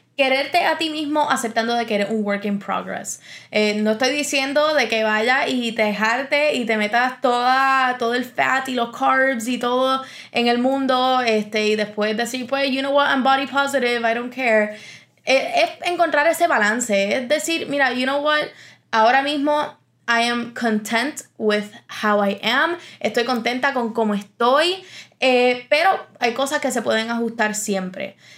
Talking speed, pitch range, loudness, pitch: 180 wpm, 220-275 Hz, -19 LUFS, 250 Hz